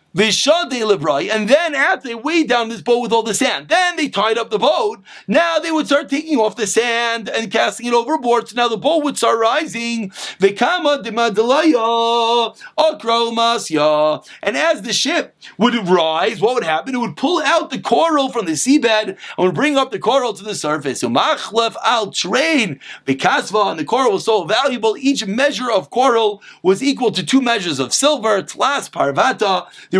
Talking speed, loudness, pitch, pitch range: 170 wpm, -16 LUFS, 235 Hz, 220-290 Hz